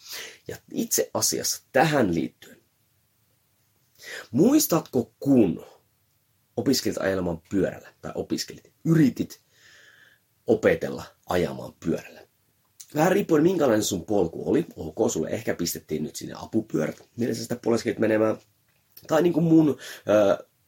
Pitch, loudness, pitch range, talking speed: 120 Hz, -24 LUFS, 105-160 Hz, 110 wpm